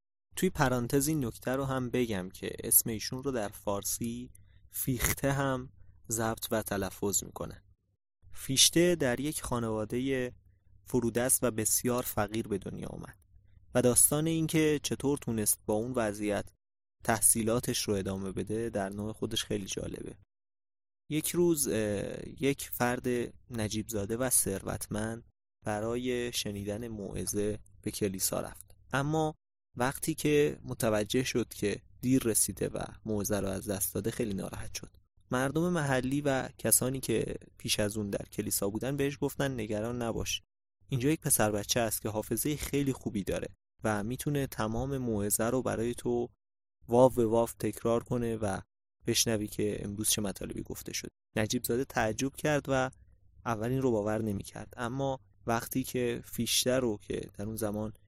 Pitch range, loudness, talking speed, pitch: 100-125 Hz, -31 LUFS, 145 wpm, 115 Hz